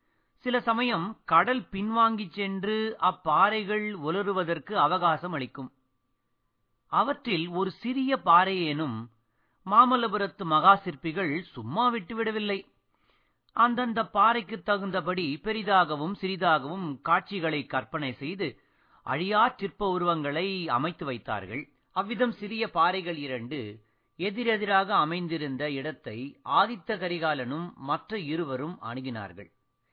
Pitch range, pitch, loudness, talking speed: 145-210 Hz, 180 Hz, -27 LUFS, 85 wpm